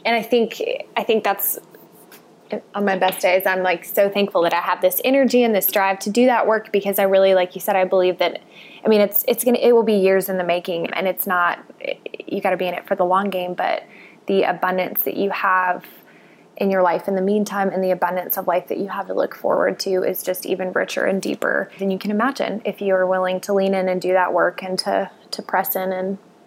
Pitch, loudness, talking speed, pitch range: 190 Hz, -20 LUFS, 250 wpm, 185-205 Hz